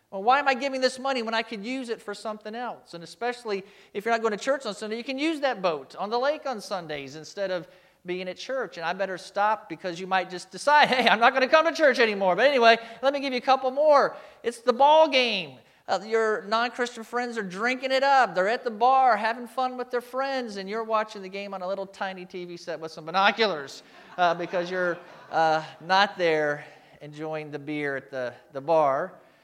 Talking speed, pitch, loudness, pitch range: 235 wpm, 215 Hz, -25 LUFS, 180-250 Hz